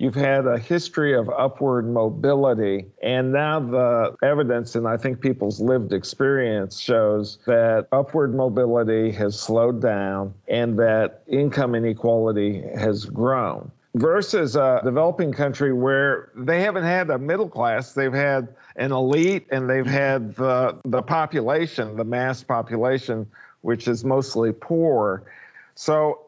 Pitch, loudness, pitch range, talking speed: 125 Hz, -22 LUFS, 115-140 Hz, 135 wpm